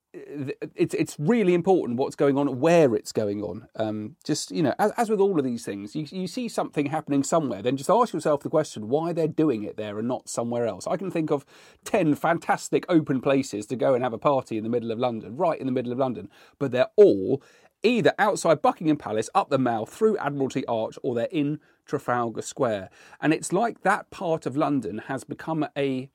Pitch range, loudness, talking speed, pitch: 125-165 Hz, -25 LUFS, 215 wpm, 145 Hz